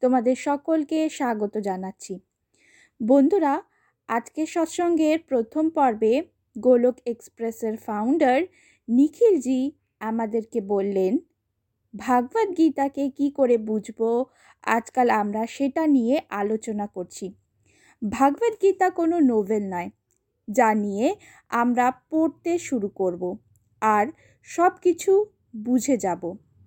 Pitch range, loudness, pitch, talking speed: 215-310 Hz, -23 LUFS, 250 Hz, 95 wpm